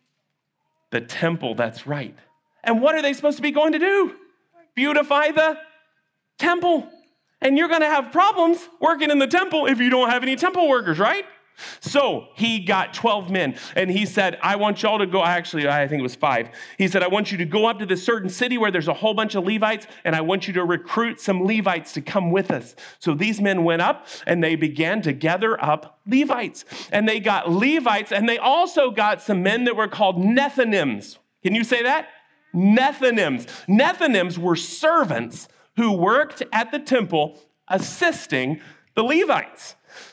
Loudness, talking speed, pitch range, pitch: -21 LUFS, 190 wpm, 185-285 Hz, 220 Hz